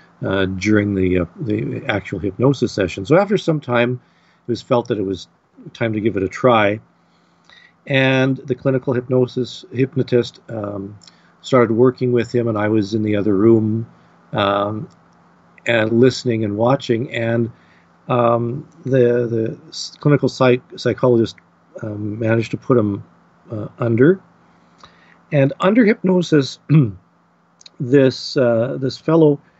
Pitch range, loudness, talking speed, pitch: 105-135 Hz, -18 LUFS, 135 wpm, 120 Hz